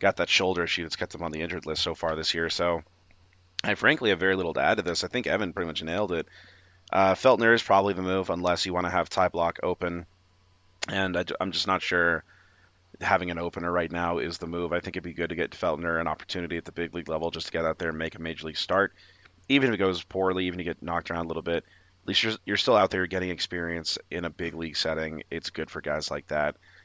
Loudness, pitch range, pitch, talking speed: -27 LUFS, 85-95 Hz, 90 Hz, 270 wpm